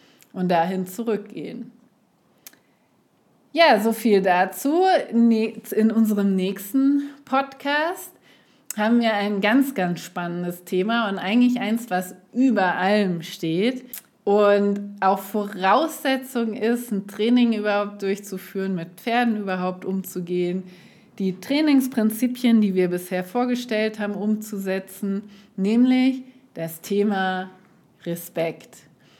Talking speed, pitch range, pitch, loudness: 100 wpm, 190-240 Hz, 205 Hz, -22 LUFS